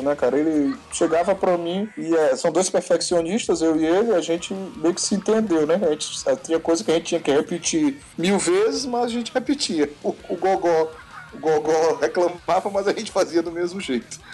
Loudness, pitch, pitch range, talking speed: -22 LUFS, 170 Hz, 160-200 Hz, 215 wpm